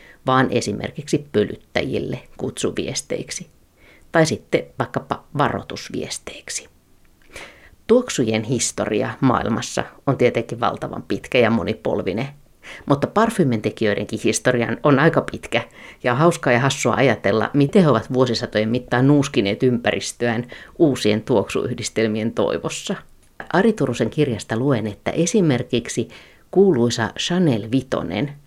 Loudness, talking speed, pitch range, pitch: -20 LUFS, 100 wpm, 115-145 Hz, 125 Hz